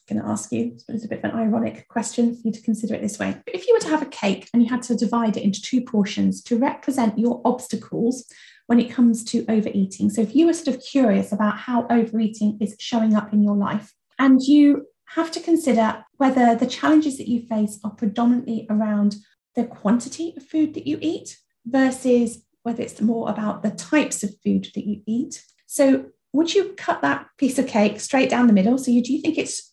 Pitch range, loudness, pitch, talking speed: 215-265 Hz, -21 LUFS, 235 Hz, 225 wpm